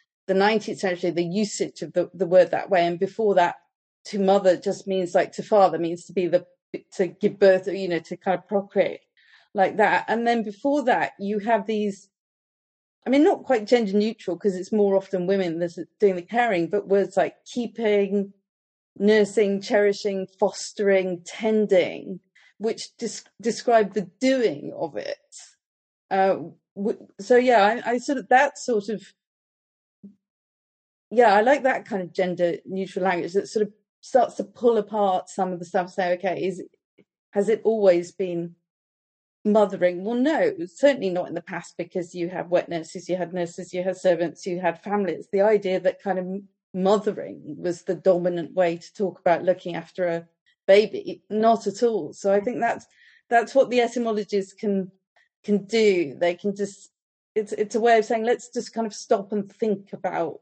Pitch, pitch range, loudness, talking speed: 200 Hz, 185-220 Hz, -23 LUFS, 180 wpm